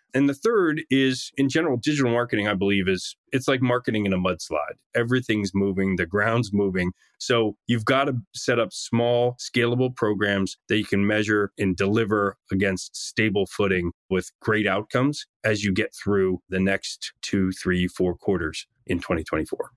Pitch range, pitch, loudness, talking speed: 95-125 Hz, 105 Hz, -24 LUFS, 165 wpm